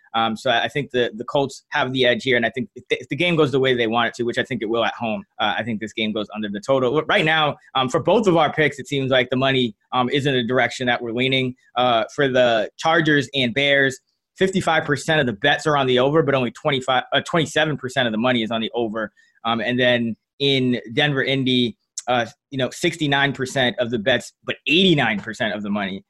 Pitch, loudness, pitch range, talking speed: 130 Hz, -20 LUFS, 120-145 Hz, 250 wpm